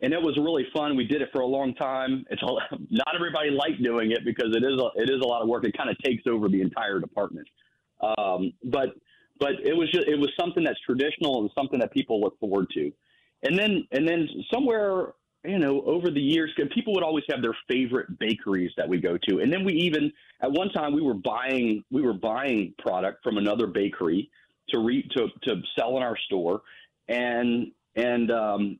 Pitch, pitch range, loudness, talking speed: 145 Hz, 120-195 Hz, -26 LUFS, 215 wpm